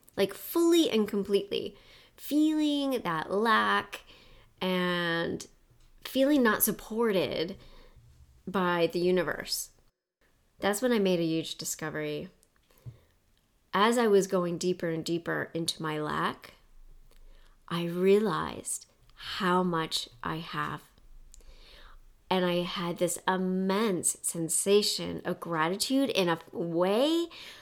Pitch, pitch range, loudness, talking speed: 180 Hz, 165-210 Hz, -29 LUFS, 105 wpm